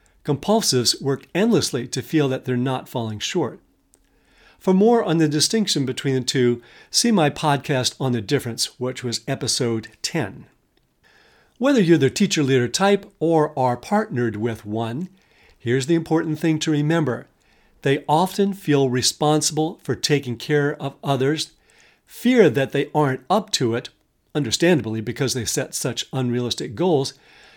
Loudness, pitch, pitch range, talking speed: -21 LUFS, 140 Hz, 125-160 Hz, 150 wpm